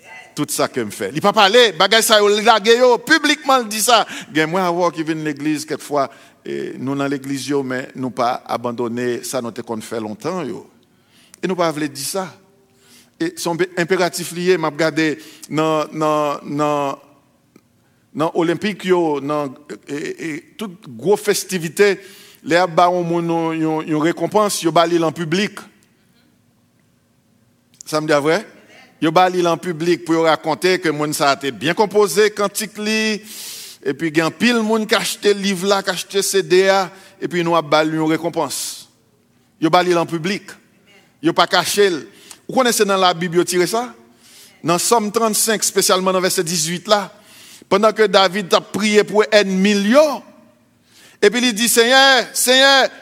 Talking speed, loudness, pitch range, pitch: 165 wpm, -17 LUFS, 155-210 Hz, 180 Hz